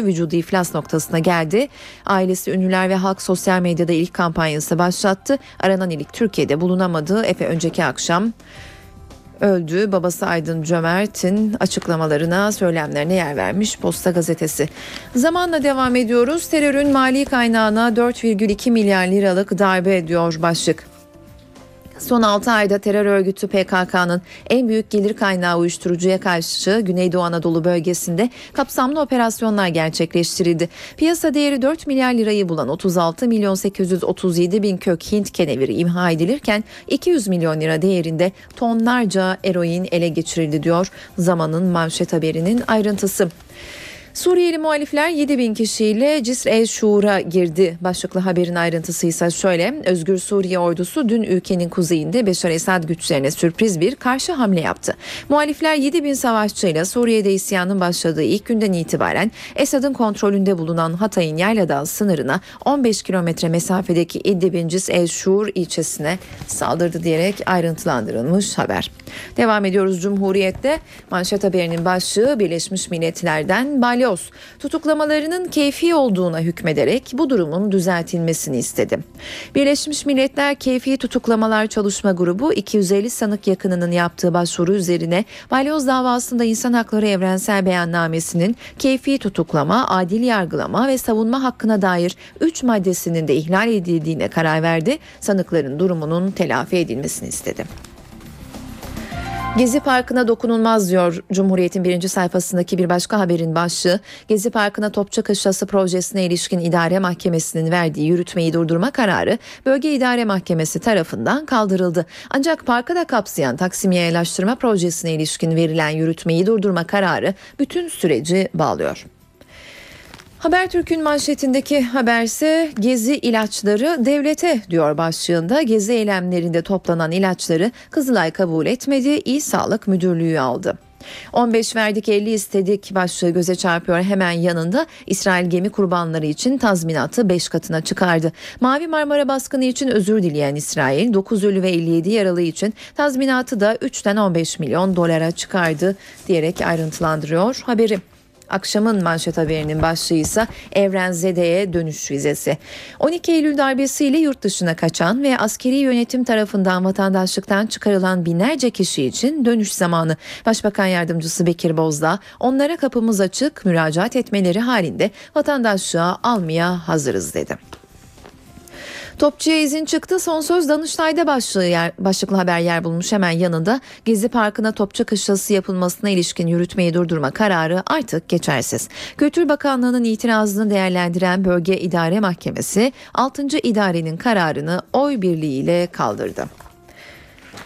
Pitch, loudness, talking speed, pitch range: 195 Hz, -18 LUFS, 120 wpm, 175-235 Hz